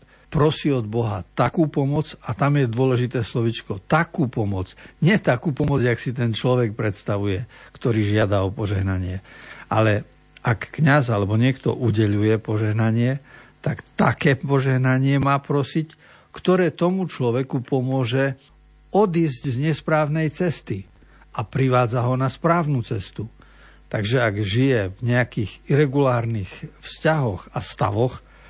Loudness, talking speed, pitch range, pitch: -22 LUFS, 125 wpm, 110-150 Hz, 130 Hz